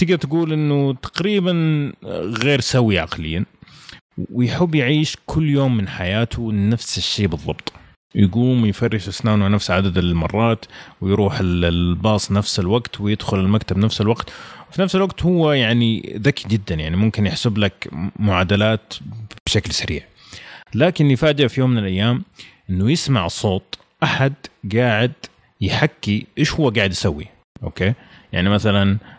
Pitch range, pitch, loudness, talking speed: 100-135 Hz, 110 Hz, -19 LUFS, 130 wpm